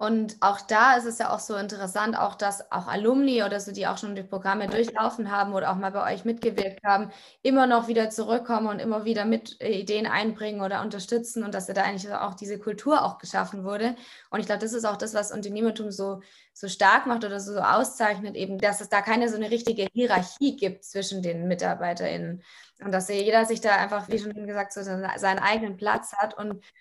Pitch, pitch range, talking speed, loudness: 205 Hz, 195-225 Hz, 215 wpm, -26 LUFS